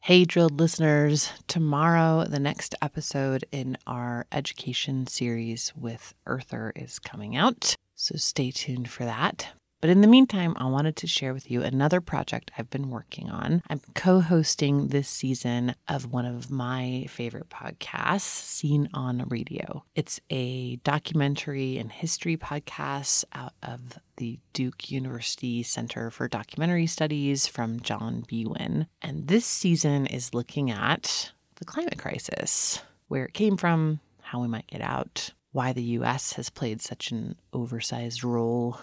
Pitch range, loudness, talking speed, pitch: 120-155 Hz, -27 LUFS, 145 wpm, 135 Hz